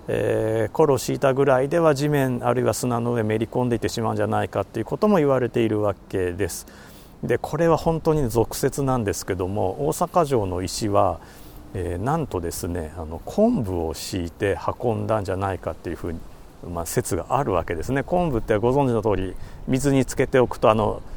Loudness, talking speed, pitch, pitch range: -23 LUFS, 395 characters per minute, 110 Hz, 95-135 Hz